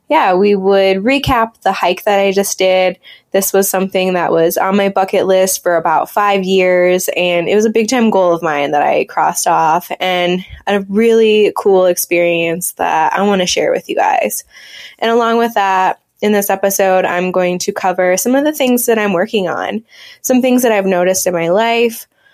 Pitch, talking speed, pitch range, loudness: 195 Hz, 205 wpm, 180-220 Hz, -13 LUFS